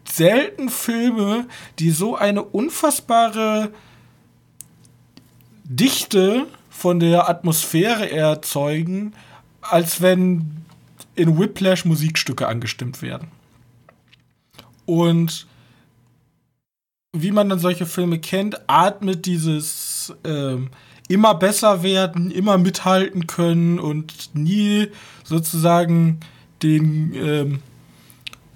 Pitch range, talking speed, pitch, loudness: 155-195 Hz, 80 wpm, 170 Hz, -19 LUFS